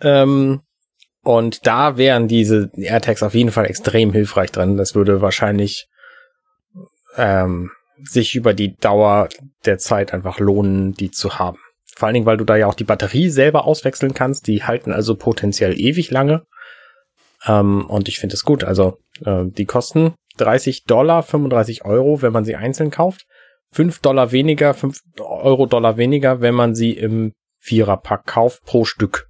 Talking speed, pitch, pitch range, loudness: 160 wpm, 115 Hz, 105-135 Hz, -16 LUFS